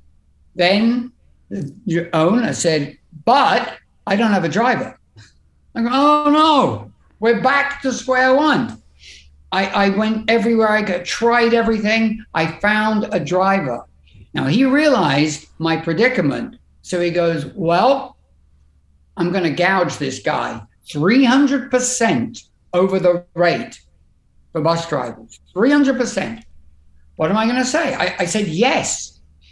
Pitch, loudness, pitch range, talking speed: 190 Hz, -17 LUFS, 150-240 Hz, 130 wpm